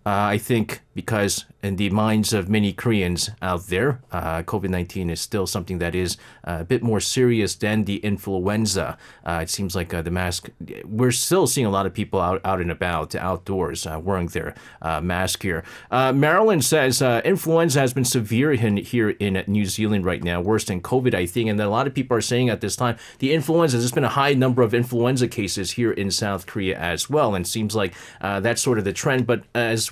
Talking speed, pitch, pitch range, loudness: 220 wpm, 105 Hz, 95-125 Hz, -22 LUFS